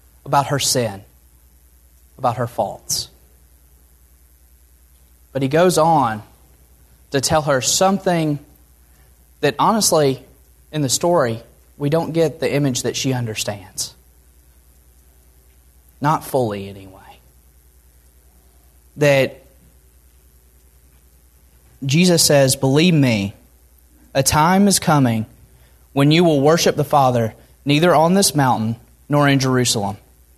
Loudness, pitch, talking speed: -17 LUFS, 95 Hz, 105 wpm